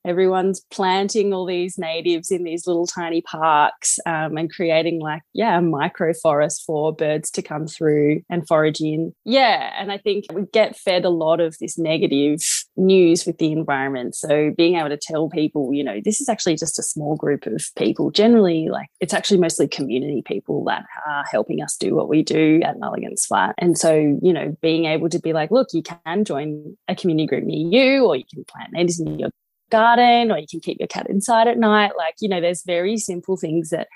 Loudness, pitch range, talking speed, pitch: -19 LUFS, 155-190 Hz, 210 wpm, 170 Hz